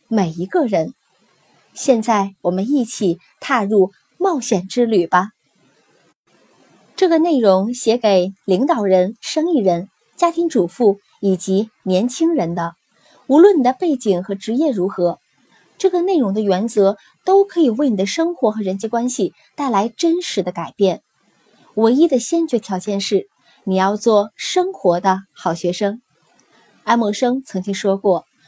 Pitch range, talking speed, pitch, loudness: 190-275 Hz, 215 characters per minute, 215 Hz, -17 LUFS